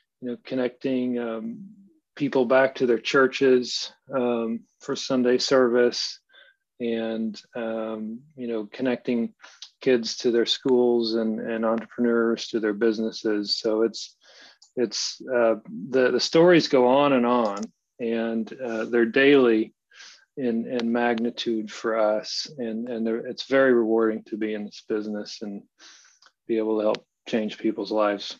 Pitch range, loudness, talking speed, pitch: 110-125 Hz, -24 LUFS, 140 wpm, 115 Hz